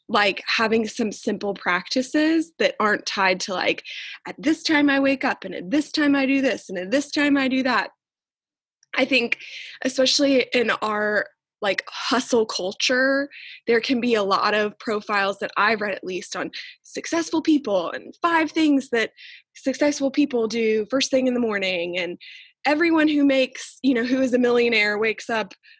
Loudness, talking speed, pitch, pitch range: -22 LUFS, 180 wpm, 260 Hz, 215-290 Hz